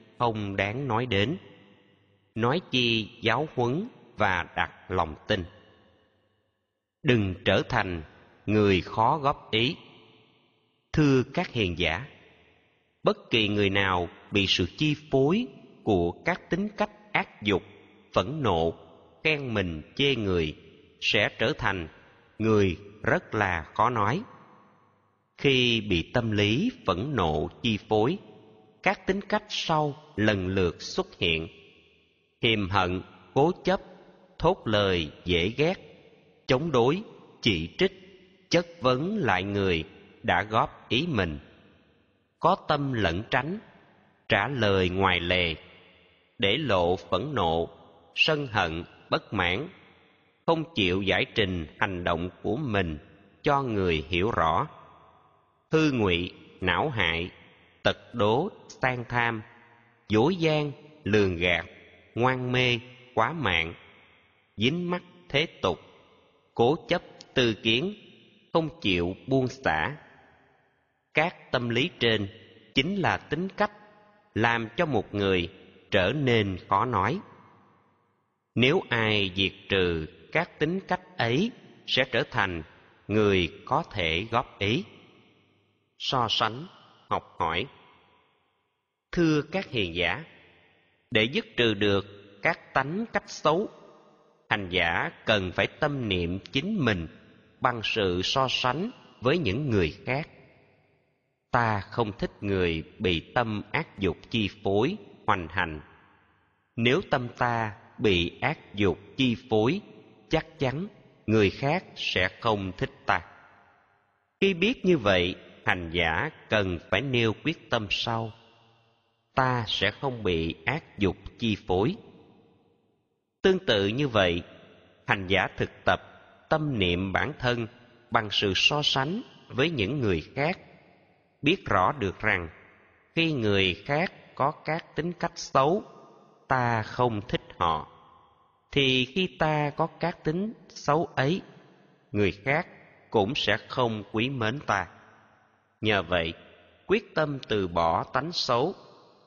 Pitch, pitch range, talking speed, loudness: 110 Hz, 95-145 Hz, 125 wpm, -27 LUFS